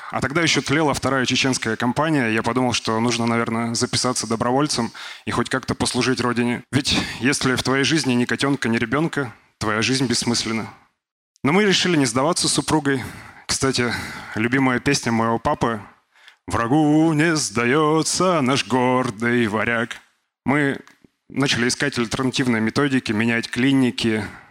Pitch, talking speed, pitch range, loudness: 125 Hz, 135 wpm, 115-140 Hz, -20 LUFS